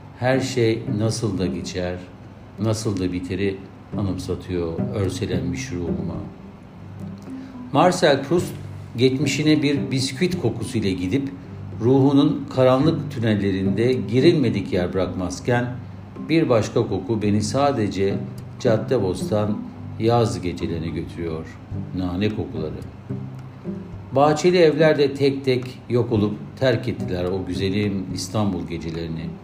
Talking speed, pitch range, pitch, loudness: 95 wpm, 90-130 Hz, 105 Hz, -22 LUFS